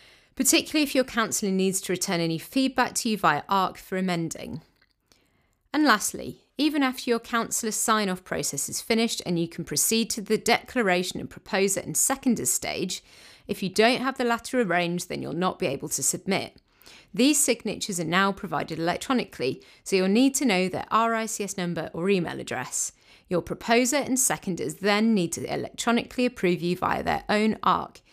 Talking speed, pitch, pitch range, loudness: 175 wpm, 205 Hz, 180-235 Hz, -25 LUFS